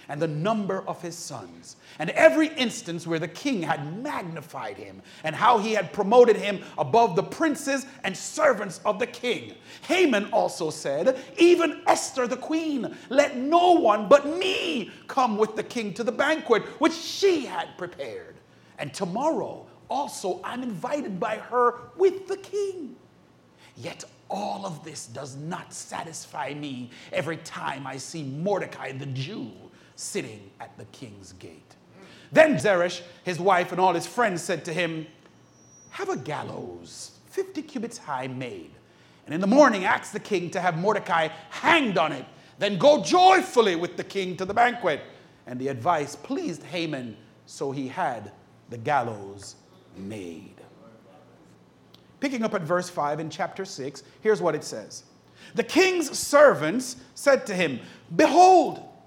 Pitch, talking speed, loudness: 205 Hz, 155 wpm, -24 LUFS